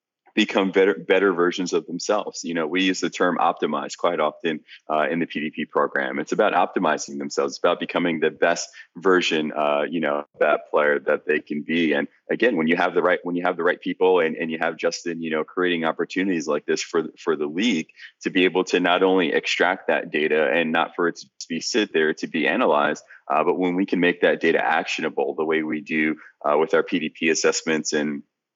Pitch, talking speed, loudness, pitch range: 80 Hz, 225 wpm, -22 LUFS, 75-90 Hz